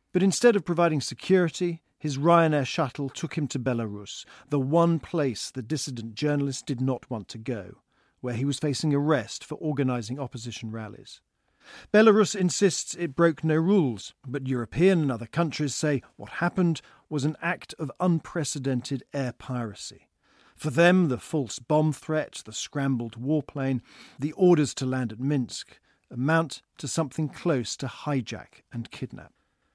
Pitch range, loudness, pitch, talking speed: 125-165 Hz, -26 LUFS, 145 Hz, 155 wpm